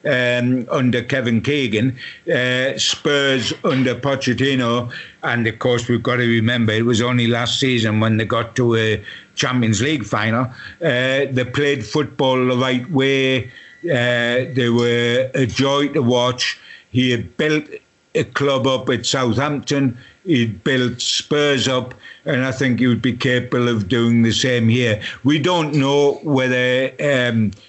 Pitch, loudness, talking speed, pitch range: 125 Hz, -18 LUFS, 155 wpm, 120-135 Hz